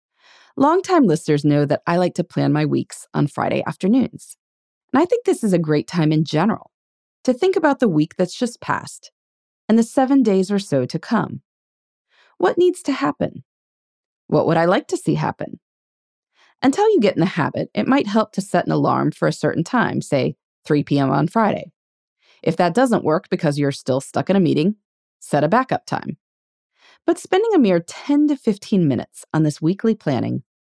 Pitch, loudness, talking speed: 190 Hz, -19 LUFS, 195 wpm